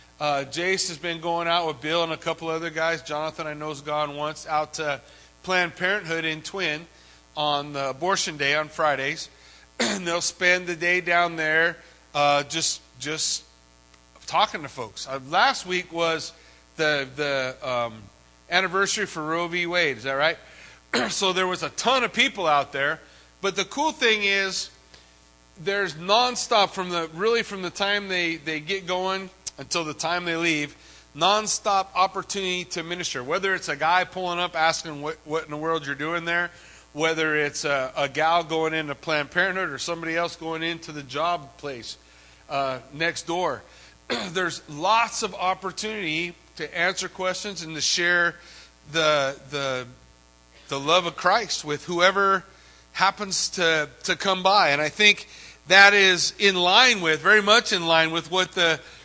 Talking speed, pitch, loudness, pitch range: 170 wpm, 165 Hz, -23 LUFS, 150-185 Hz